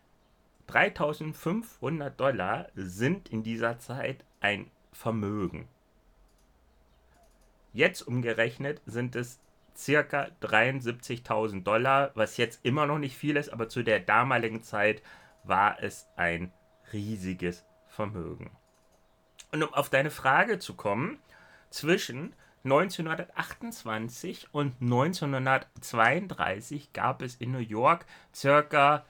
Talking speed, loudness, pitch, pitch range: 100 wpm, -29 LUFS, 125 Hz, 110-145 Hz